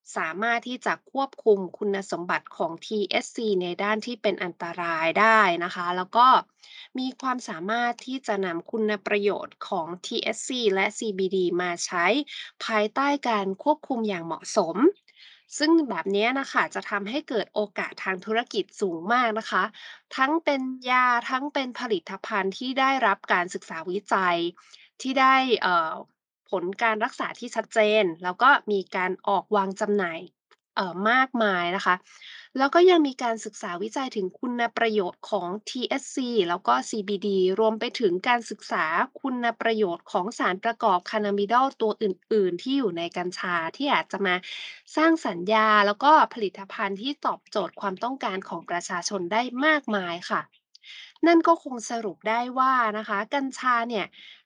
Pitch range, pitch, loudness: 195-260 Hz, 220 Hz, -25 LUFS